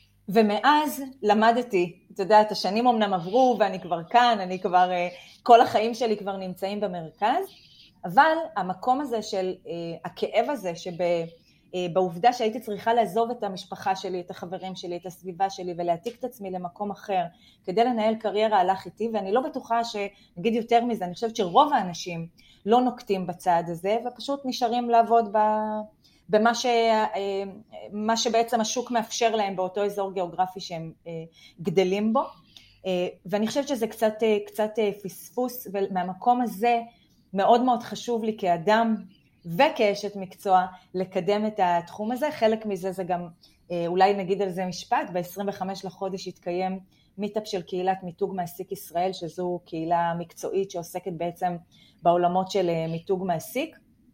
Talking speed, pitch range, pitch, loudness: 140 wpm, 180-230 Hz, 200 Hz, -25 LUFS